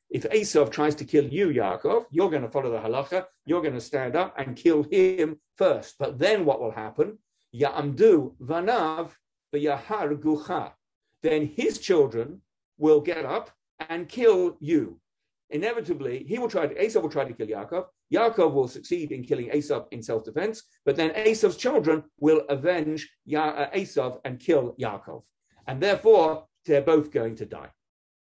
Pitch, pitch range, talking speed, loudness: 160 Hz, 150-220 Hz, 165 wpm, -25 LUFS